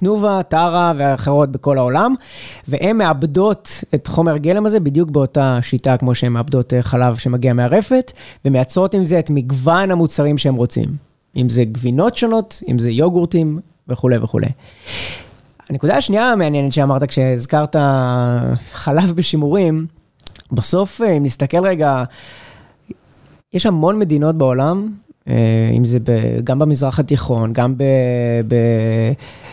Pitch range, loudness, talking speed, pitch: 125-170 Hz, -16 LUFS, 125 wpm, 140 Hz